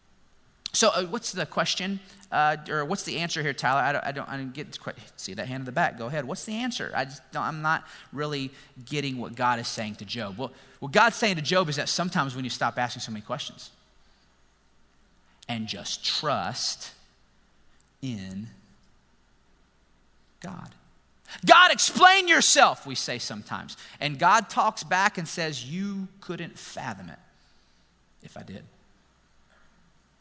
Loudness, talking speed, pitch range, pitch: -25 LUFS, 170 wpm, 115-175 Hz, 140 Hz